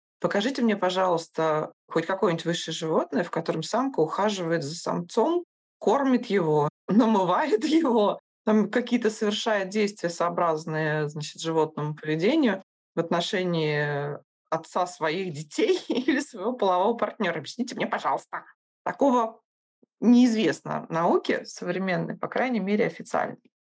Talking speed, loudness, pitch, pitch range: 115 wpm, -26 LUFS, 190 Hz, 165-235 Hz